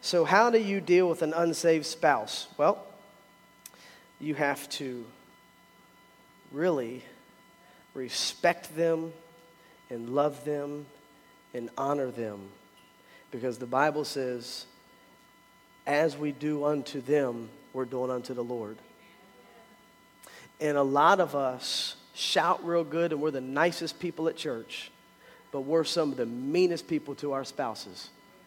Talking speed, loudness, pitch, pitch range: 130 wpm, -29 LUFS, 145 Hz, 130-165 Hz